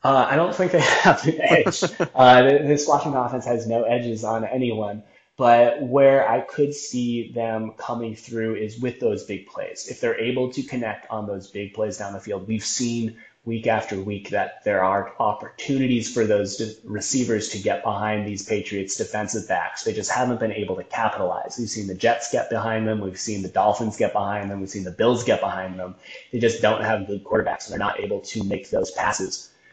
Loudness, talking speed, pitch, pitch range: -22 LUFS, 210 wpm, 115 Hz, 105-125 Hz